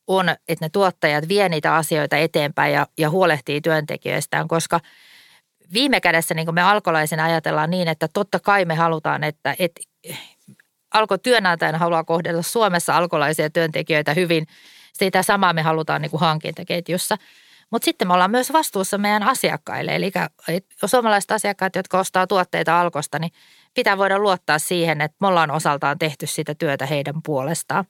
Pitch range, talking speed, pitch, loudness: 160-195 Hz, 155 wpm, 170 Hz, -20 LUFS